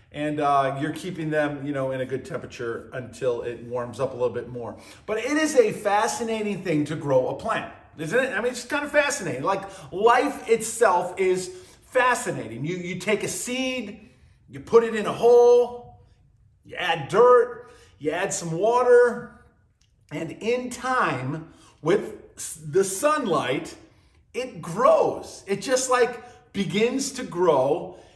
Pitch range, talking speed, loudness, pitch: 150-245 Hz, 160 wpm, -23 LUFS, 195 Hz